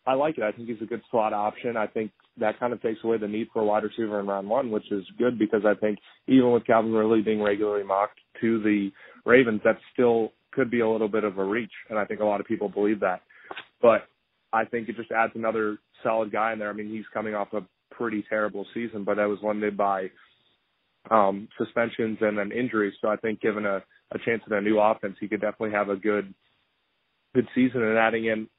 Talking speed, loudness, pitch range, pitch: 235 wpm, -26 LUFS, 105-115 Hz, 110 Hz